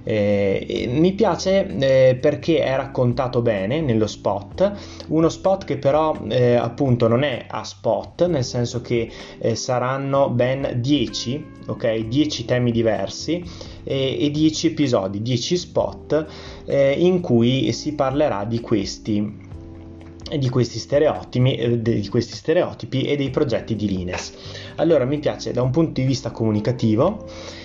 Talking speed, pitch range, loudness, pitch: 140 wpm, 110-145 Hz, -21 LUFS, 125 Hz